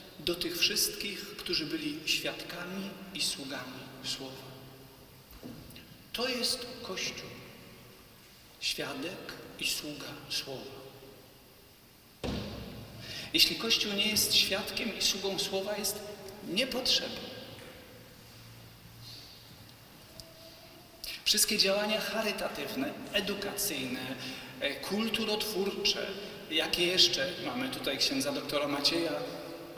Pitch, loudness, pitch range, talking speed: 195 Hz, -31 LUFS, 145-215 Hz, 75 wpm